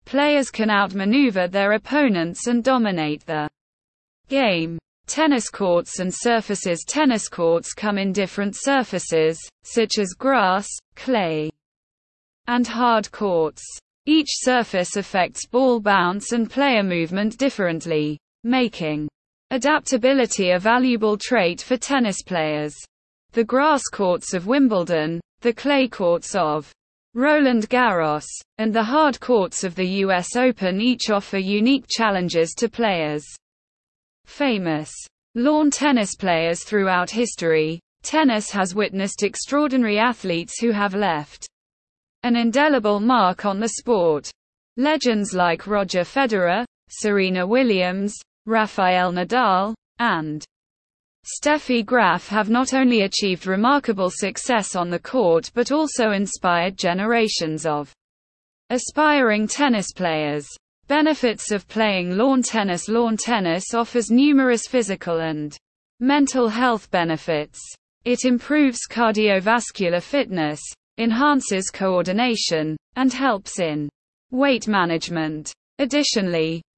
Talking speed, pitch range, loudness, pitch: 110 wpm, 175-245 Hz, -20 LUFS, 210 Hz